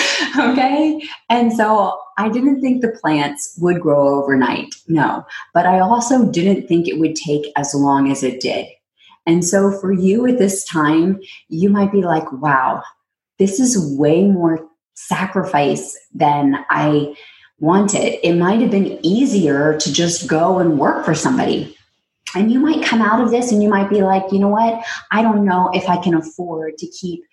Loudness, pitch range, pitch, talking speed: -16 LUFS, 160-210 Hz, 185 Hz, 180 wpm